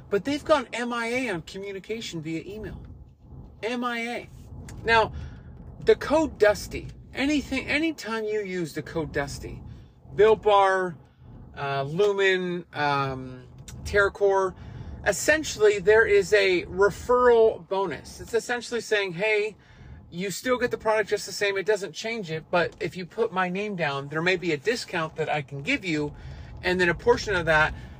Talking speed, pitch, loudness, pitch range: 155 wpm, 200 Hz, -25 LUFS, 165-225 Hz